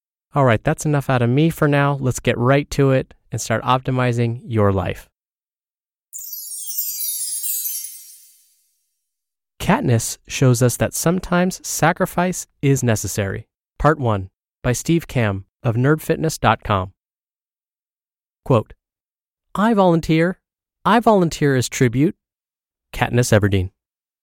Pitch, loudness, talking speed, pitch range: 125 Hz, -19 LUFS, 105 wpm, 105-155 Hz